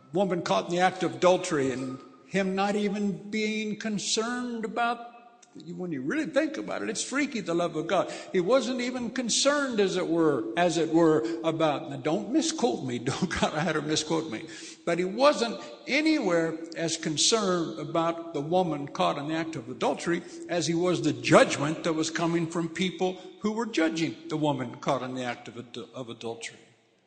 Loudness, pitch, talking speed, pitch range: -27 LUFS, 175 Hz, 185 wpm, 160-215 Hz